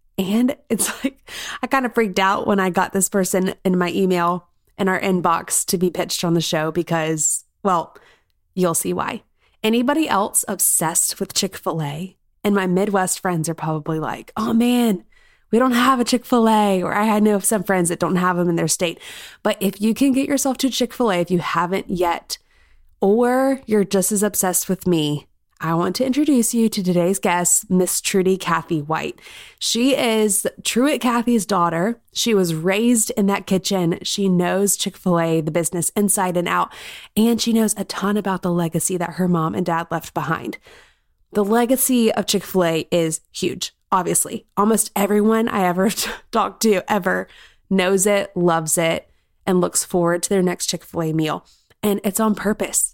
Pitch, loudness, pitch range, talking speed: 195 Hz, -19 LUFS, 175-220 Hz, 190 wpm